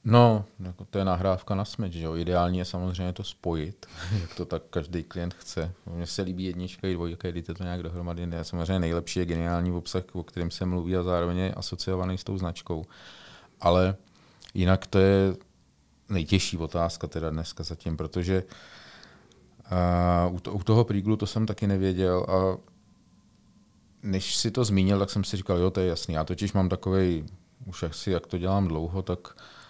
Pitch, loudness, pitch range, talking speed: 90 Hz, -28 LUFS, 85-95 Hz, 175 wpm